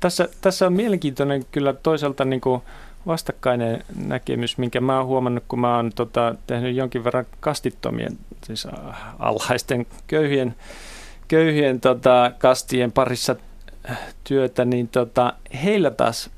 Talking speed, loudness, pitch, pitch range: 120 wpm, -21 LUFS, 130 Hz, 125-140 Hz